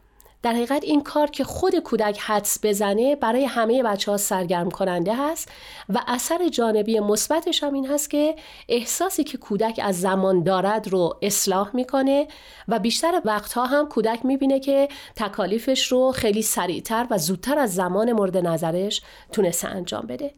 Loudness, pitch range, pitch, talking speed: -22 LUFS, 205-275 Hz, 230 Hz, 155 wpm